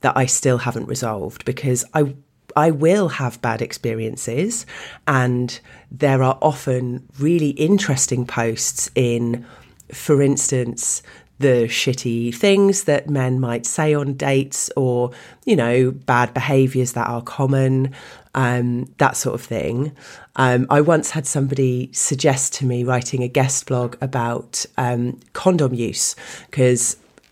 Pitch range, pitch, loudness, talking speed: 125-140 Hz, 130 Hz, -19 LUFS, 135 wpm